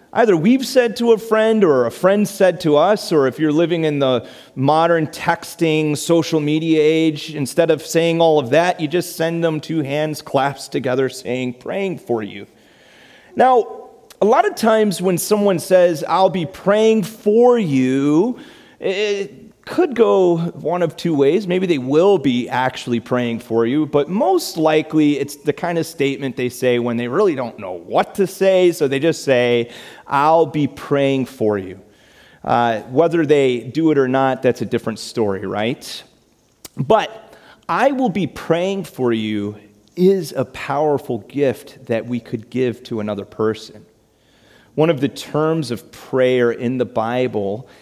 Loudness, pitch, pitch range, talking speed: -17 LUFS, 150 Hz, 125-175 Hz, 170 wpm